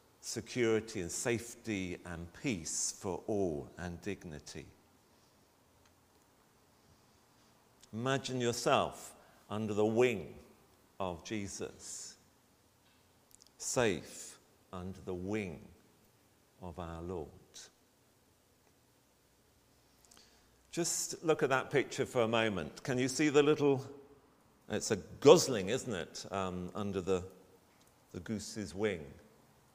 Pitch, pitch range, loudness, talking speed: 105 Hz, 95-125 Hz, -35 LUFS, 95 wpm